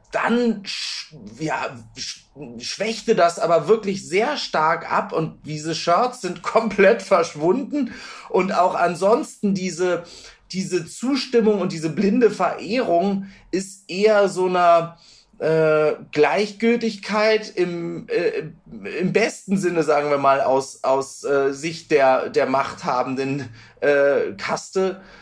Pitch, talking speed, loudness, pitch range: 180 Hz, 120 wpm, -21 LUFS, 155-215 Hz